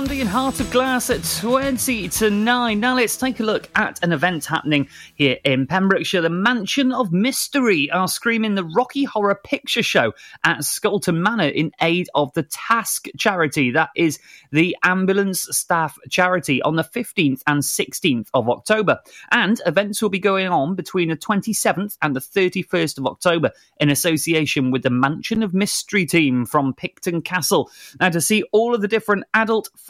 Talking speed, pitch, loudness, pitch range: 175 wpm, 185 Hz, -19 LUFS, 160-225 Hz